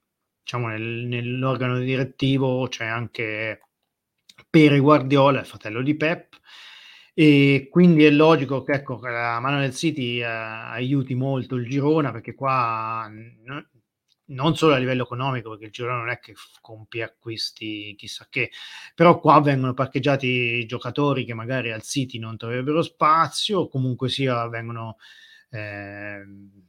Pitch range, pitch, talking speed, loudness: 115-140 Hz, 125 Hz, 145 wpm, -22 LUFS